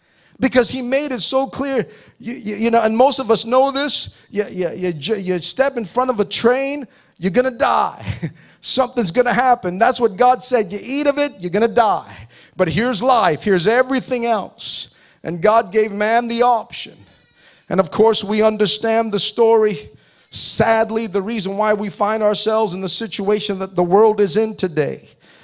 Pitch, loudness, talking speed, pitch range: 225 Hz, -17 LUFS, 185 wpm, 205-250 Hz